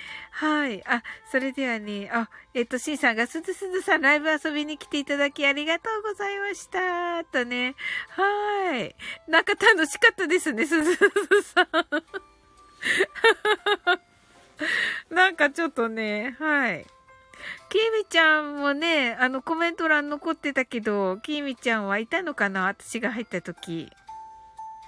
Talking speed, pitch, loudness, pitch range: 285 characters per minute, 315 Hz, -24 LUFS, 260-385 Hz